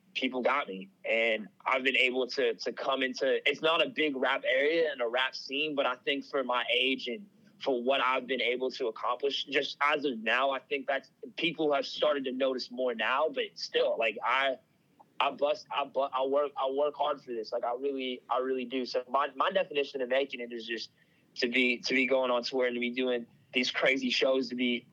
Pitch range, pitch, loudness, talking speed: 125-145 Hz, 135 Hz, -30 LUFS, 230 wpm